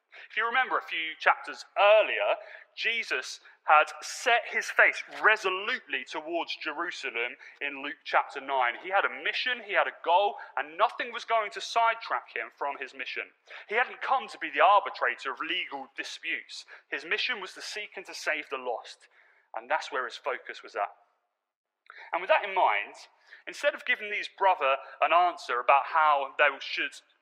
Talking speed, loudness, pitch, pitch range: 175 wpm, -28 LUFS, 215 Hz, 190-260 Hz